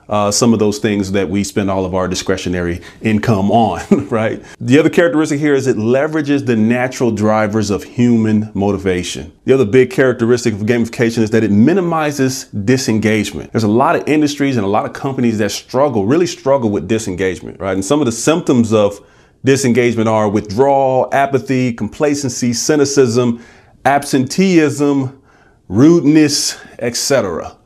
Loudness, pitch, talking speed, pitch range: -14 LUFS, 120 Hz, 155 wpm, 105-135 Hz